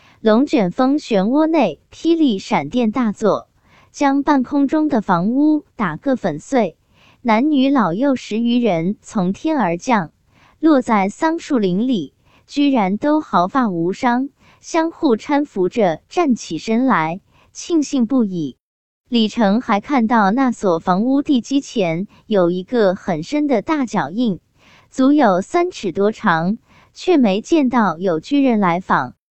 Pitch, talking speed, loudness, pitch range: 235 Hz, 195 characters per minute, -17 LUFS, 190-280 Hz